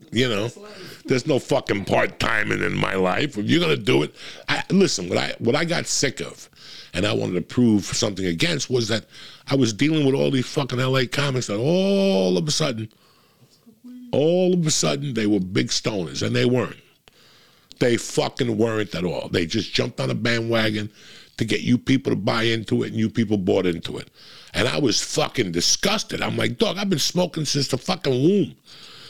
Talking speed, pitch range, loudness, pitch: 200 wpm, 110-150 Hz, -22 LUFS, 125 Hz